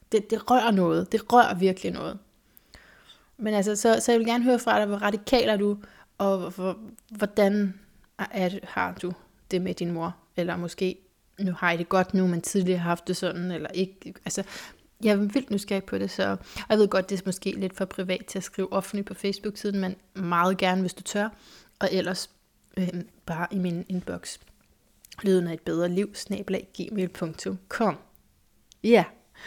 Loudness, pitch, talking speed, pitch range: -27 LUFS, 190 Hz, 200 wpm, 180-205 Hz